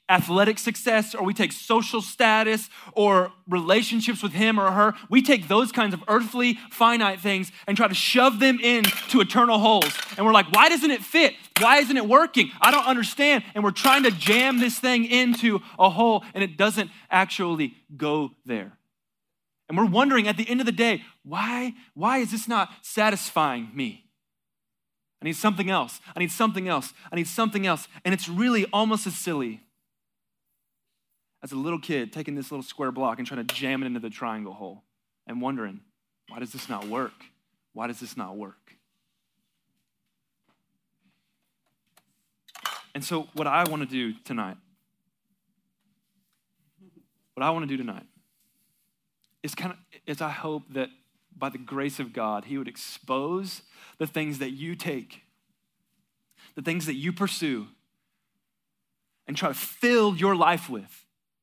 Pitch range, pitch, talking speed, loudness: 165-225 Hz, 200 Hz, 165 wpm, -23 LUFS